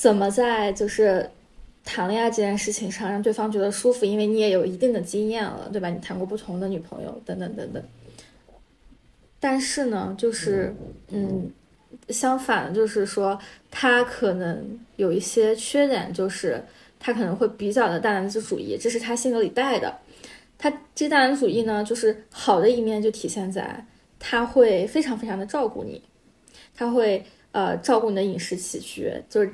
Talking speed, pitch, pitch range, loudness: 260 characters per minute, 220 Hz, 200-235 Hz, -24 LUFS